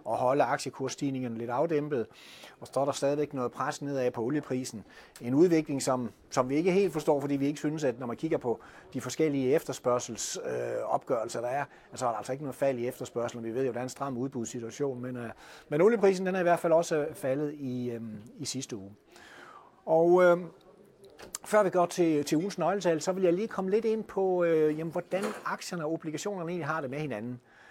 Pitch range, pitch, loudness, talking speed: 125-165 Hz, 145 Hz, -30 LUFS, 215 wpm